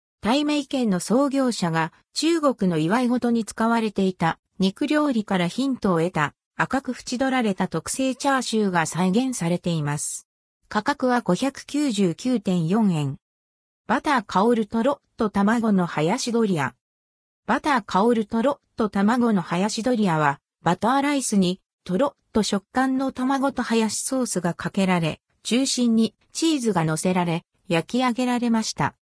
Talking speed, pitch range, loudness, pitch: 285 characters per minute, 175-255 Hz, -23 LUFS, 220 Hz